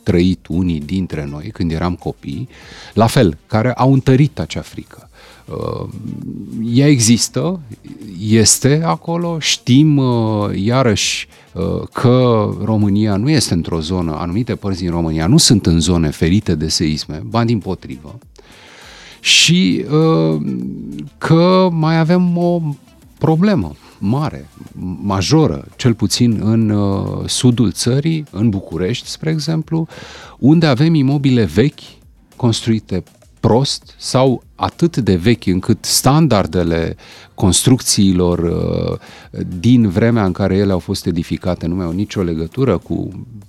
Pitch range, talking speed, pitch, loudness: 90-135 Hz, 120 wpm, 110 Hz, -15 LUFS